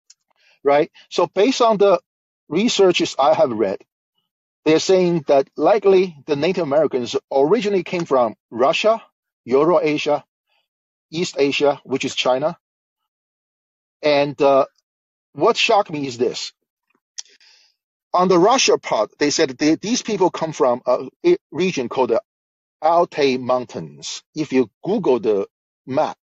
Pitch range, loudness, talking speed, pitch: 135-195 Hz, -18 LUFS, 125 wpm, 155 Hz